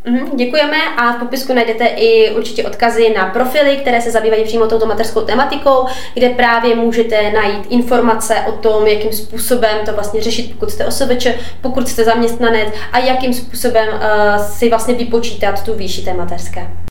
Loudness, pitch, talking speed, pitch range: -14 LUFS, 230 Hz, 165 wpm, 220-245 Hz